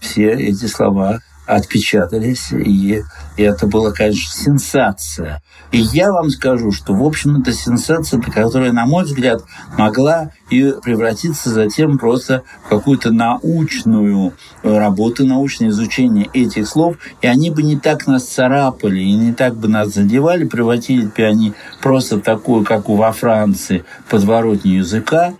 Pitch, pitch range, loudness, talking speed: 115 Hz, 105-140 Hz, -14 LUFS, 140 wpm